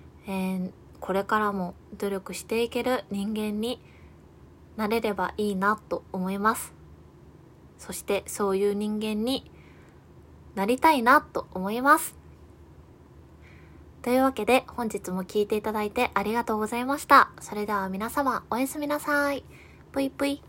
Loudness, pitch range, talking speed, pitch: -26 LUFS, 195-250 Hz, 275 characters per minute, 215 Hz